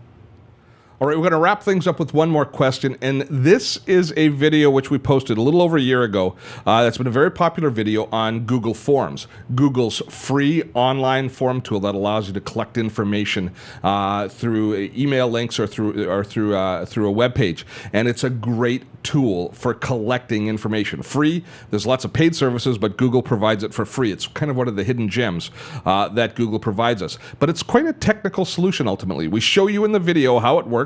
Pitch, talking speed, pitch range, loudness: 125 Hz, 210 wpm, 110-145 Hz, -19 LUFS